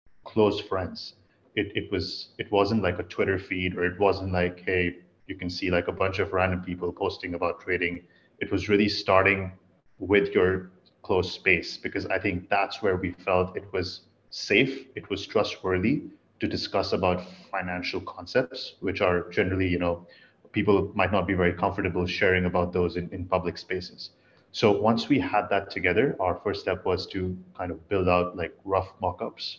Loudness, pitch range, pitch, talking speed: -27 LUFS, 90-95 Hz, 90 Hz, 185 wpm